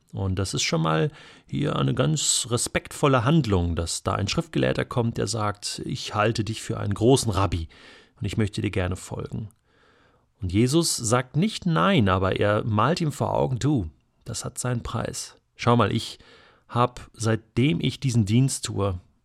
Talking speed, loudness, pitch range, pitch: 170 wpm, -24 LUFS, 100-130 Hz, 115 Hz